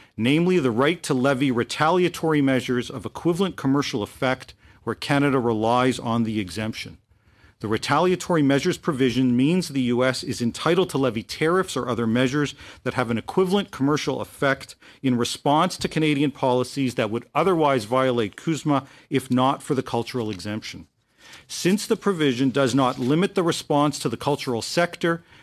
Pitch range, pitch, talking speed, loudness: 120-150 Hz, 135 Hz, 155 wpm, -23 LUFS